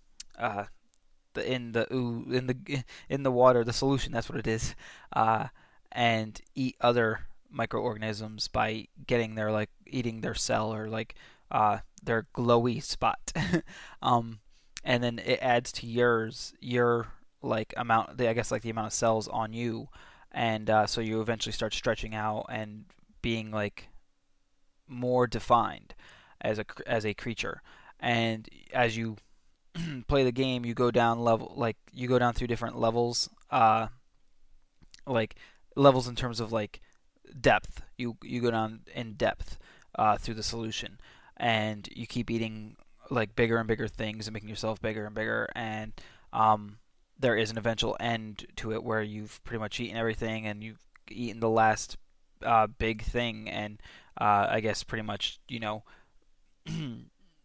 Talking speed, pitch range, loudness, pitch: 160 wpm, 110-120 Hz, -30 LUFS, 115 Hz